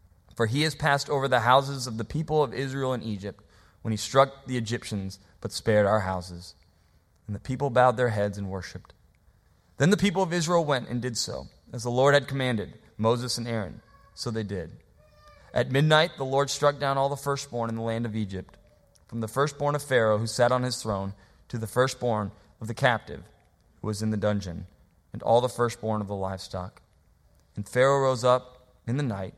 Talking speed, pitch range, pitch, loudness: 205 wpm, 100-130 Hz, 115 Hz, -26 LUFS